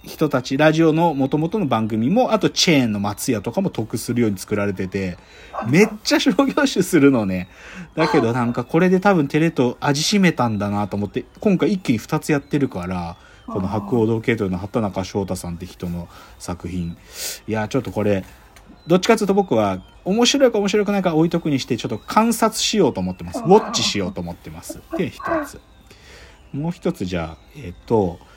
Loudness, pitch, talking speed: -19 LUFS, 125 Hz, 390 characters per minute